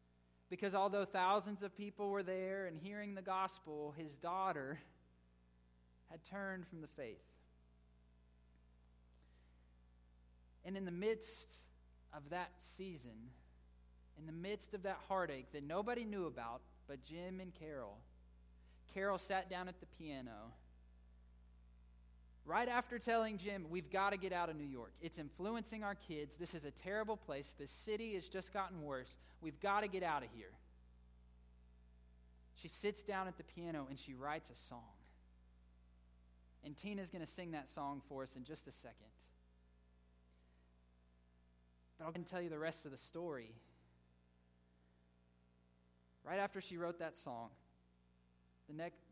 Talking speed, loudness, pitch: 145 wpm, -45 LUFS, 135 Hz